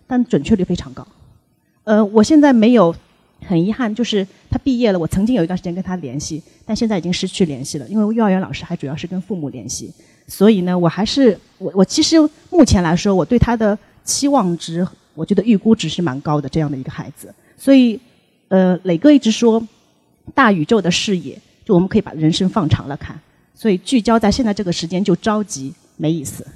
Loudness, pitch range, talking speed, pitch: -16 LUFS, 165-225 Hz, 320 characters per minute, 190 Hz